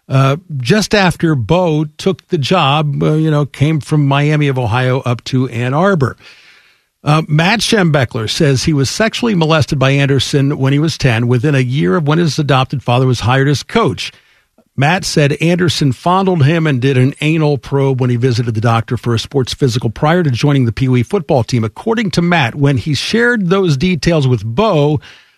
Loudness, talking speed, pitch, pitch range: -13 LUFS, 195 wpm, 145 Hz, 130-165 Hz